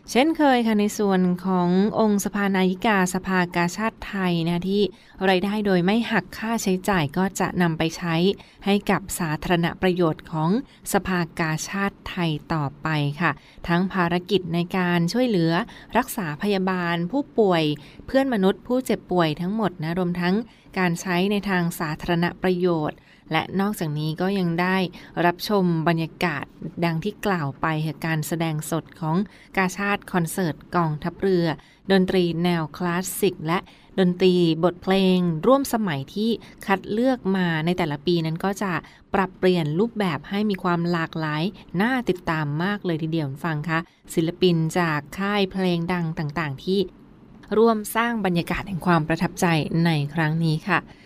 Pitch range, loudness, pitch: 165-195 Hz, -23 LUFS, 180 Hz